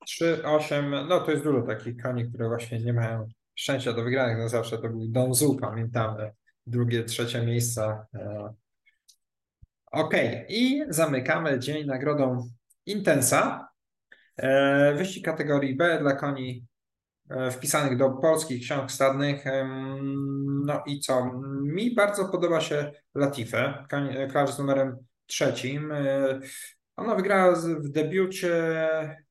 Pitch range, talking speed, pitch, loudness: 120-155 Hz, 115 wpm, 140 Hz, -26 LUFS